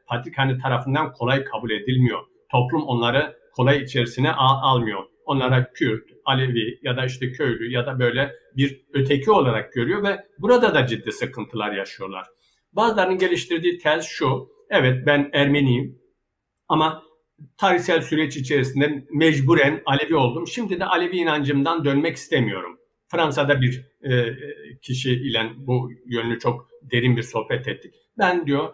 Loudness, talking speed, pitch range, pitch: -21 LUFS, 130 wpm, 125-160 Hz, 140 Hz